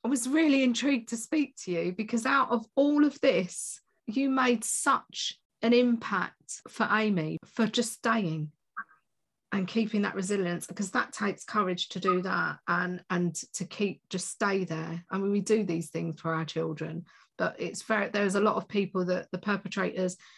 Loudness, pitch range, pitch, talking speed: -29 LUFS, 180-235 Hz, 205 Hz, 185 wpm